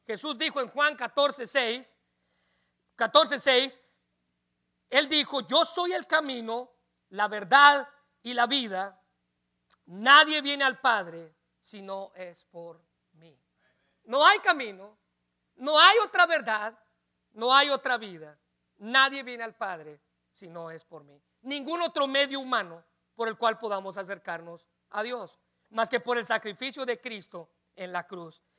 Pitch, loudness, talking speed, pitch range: 225 Hz, -25 LUFS, 140 wpm, 170-275 Hz